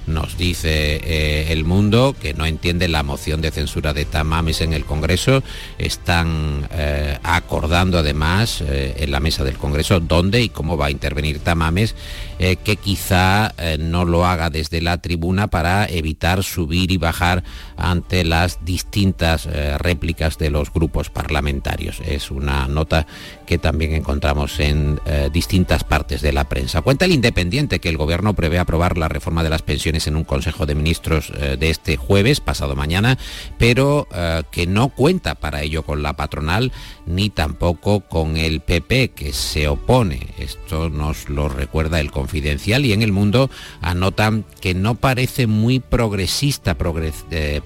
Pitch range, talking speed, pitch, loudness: 75-95 Hz, 165 wpm, 80 Hz, -19 LUFS